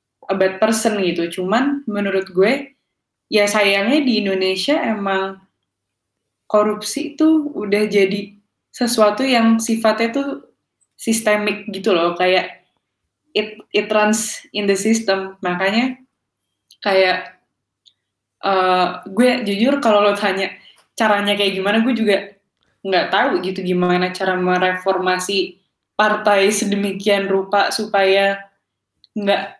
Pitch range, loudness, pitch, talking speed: 190-220 Hz, -17 LUFS, 200 Hz, 110 wpm